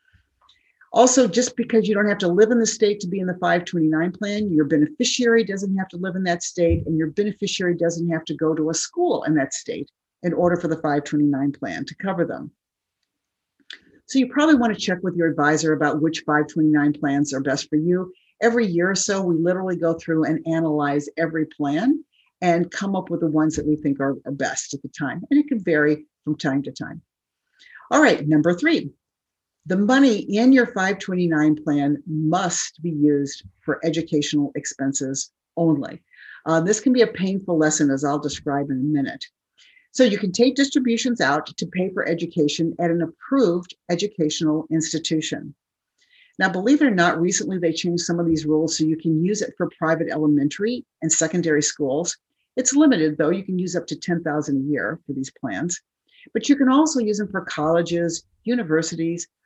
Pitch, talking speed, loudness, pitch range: 170 Hz, 195 wpm, -21 LUFS, 155-205 Hz